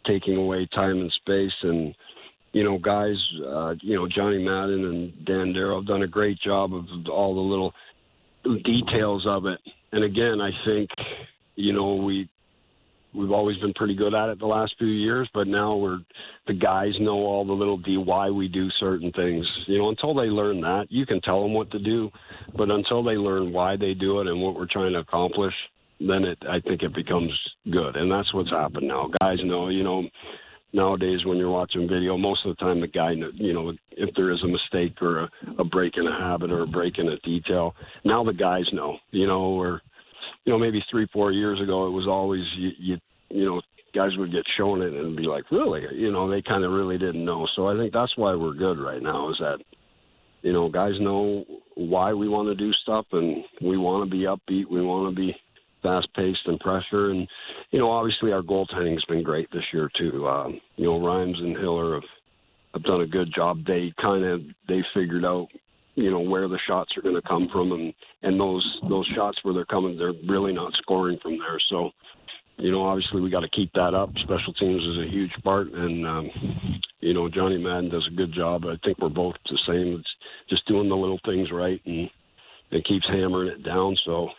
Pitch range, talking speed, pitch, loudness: 90-100 Hz, 220 wpm, 95 Hz, -25 LUFS